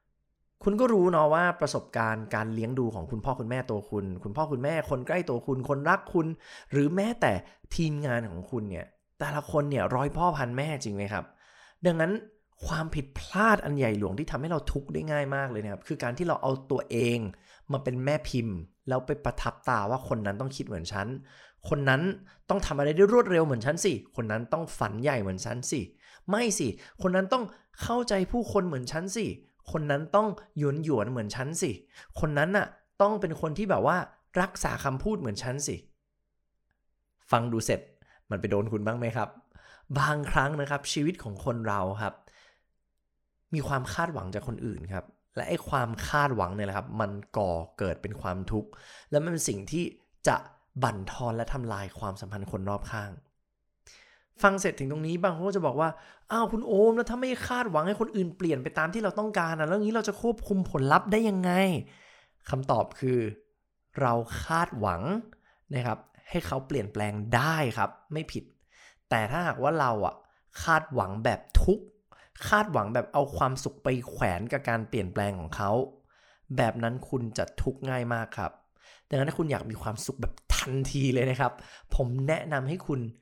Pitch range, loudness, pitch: 110-165 Hz, -29 LUFS, 135 Hz